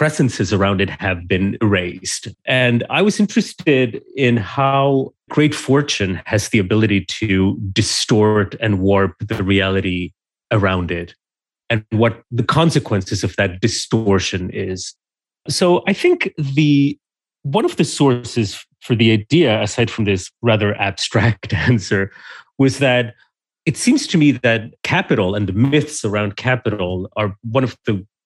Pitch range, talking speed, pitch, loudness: 100-135 Hz, 140 wpm, 115 Hz, -17 LUFS